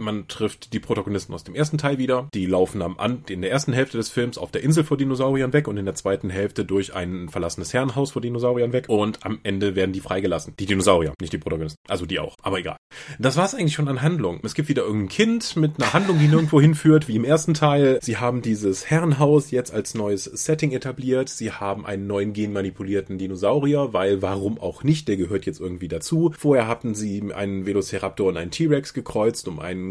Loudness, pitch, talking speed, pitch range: -22 LUFS, 120 Hz, 220 wpm, 100-145 Hz